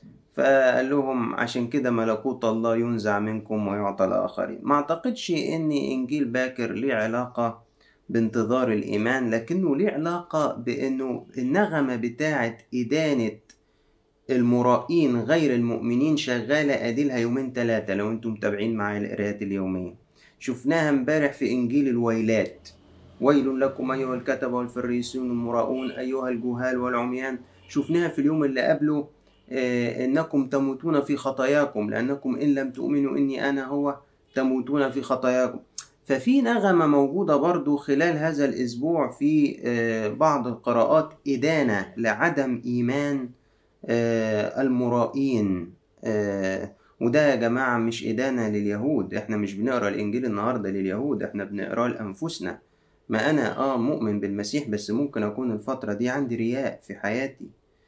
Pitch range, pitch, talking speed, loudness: 115-140 Hz, 125 Hz, 120 wpm, -25 LUFS